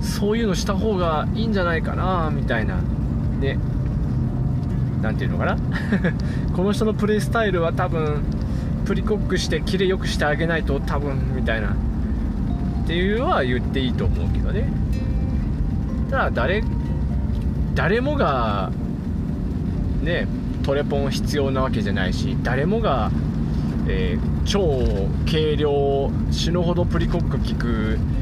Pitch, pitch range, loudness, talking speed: 75 Hz, 75-110 Hz, -22 LUFS, 270 characters per minute